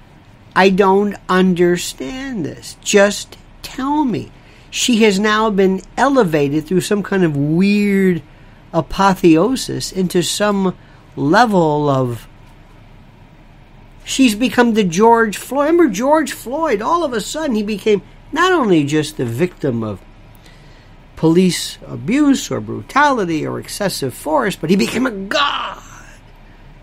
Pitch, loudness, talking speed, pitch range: 185 Hz, -16 LUFS, 120 wpm, 145-225 Hz